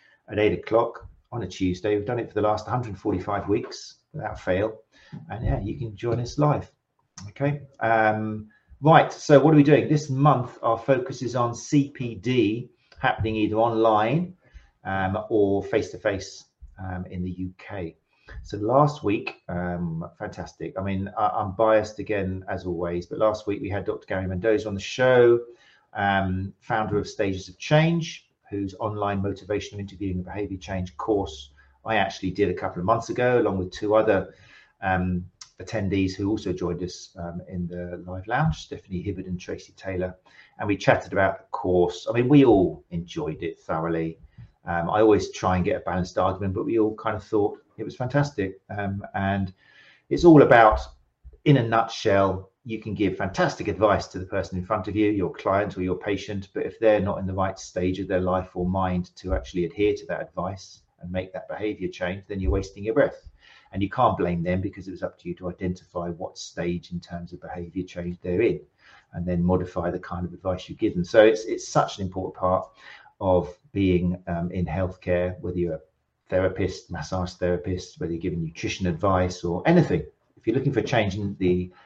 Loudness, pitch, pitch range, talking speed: -25 LUFS, 95 Hz, 90-110 Hz, 195 wpm